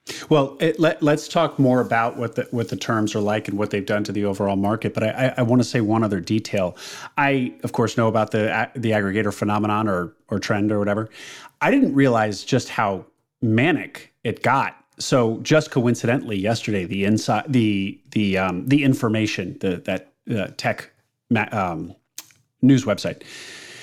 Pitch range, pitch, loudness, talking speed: 105-125 Hz, 110 Hz, -21 LUFS, 185 wpm